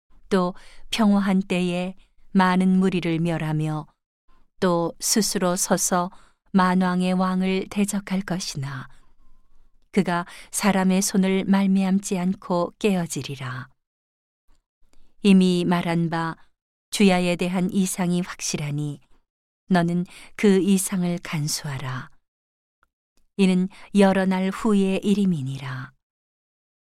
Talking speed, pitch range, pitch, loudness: 195 characters per minute, 165-190 Hz, 180 Hz, -22 LUFS